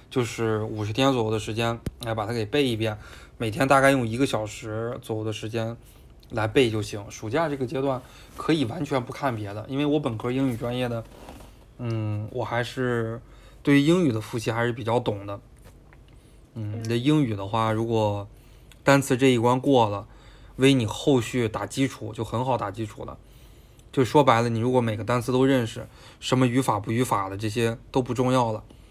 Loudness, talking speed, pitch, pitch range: -25 LUFS, 280 characters per minute, 115 Hz, 110-130 Hz